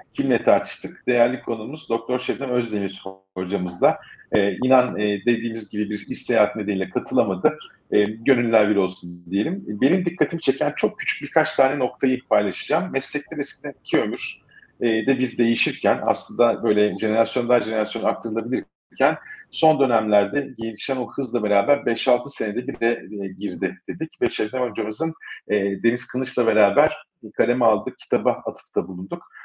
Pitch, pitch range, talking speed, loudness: 115 Hz, 105-130 Hz, 145 wpm, -22 LUFS